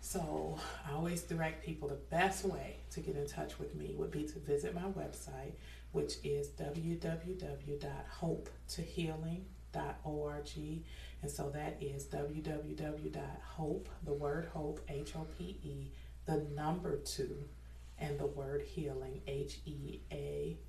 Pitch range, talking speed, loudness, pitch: 140-160 Hz, 135 wpm, -42 LUFS, 145 Hz